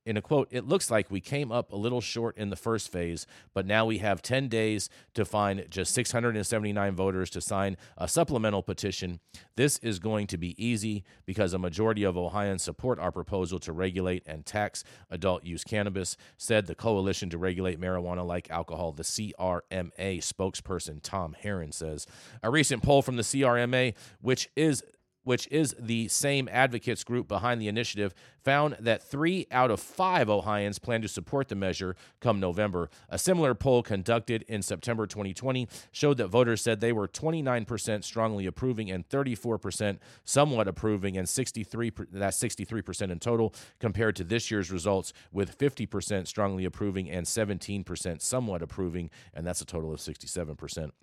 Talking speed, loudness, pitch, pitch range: 170 wpm, -30 LUFS, 105 Hz, 95-120 Hz